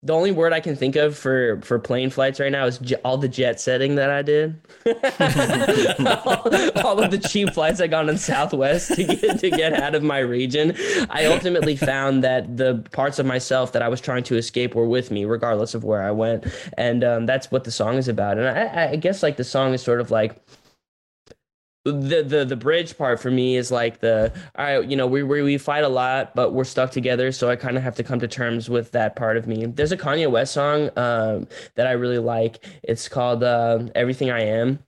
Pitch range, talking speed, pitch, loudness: 120-145 Hz, 230 wpm, 130 Hz, -21 LUFS